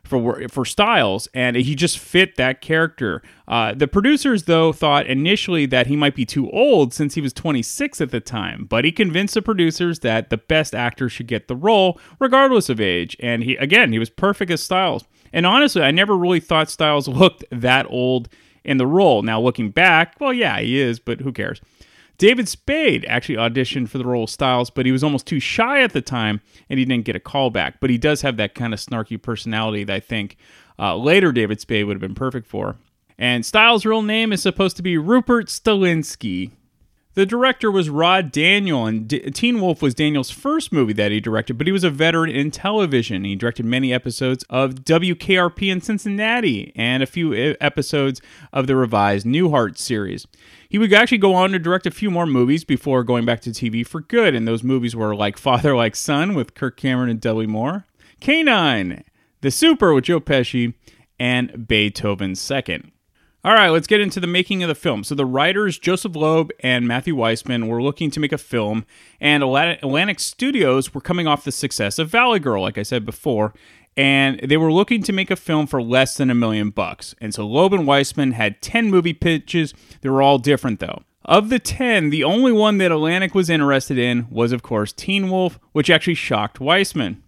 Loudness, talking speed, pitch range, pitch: -18 LUFS, 205 wpm, 120-180 Hz, 140 Hz